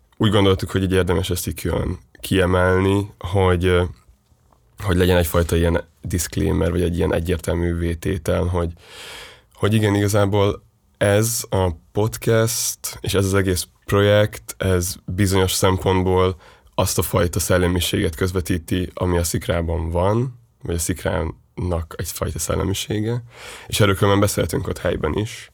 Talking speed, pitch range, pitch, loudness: 130 wpm, 90-105 Hz, 95 Hz, -20 LUFS